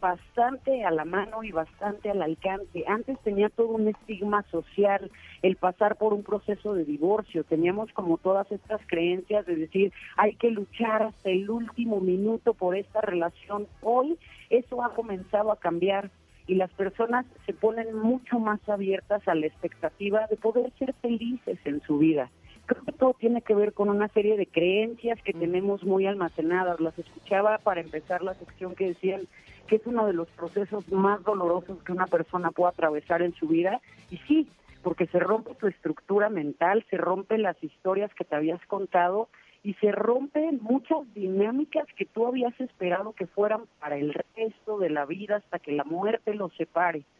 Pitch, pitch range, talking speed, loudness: 200 Hz, 180-220 Hz, 180 wpm, -28 LUFS